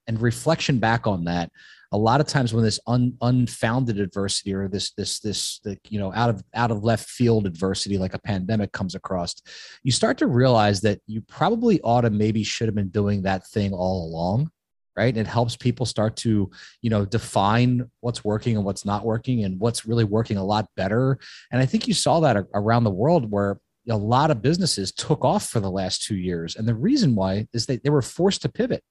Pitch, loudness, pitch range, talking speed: 110 Hz, -23 LUFS, 100-125 Hz, 220 wpm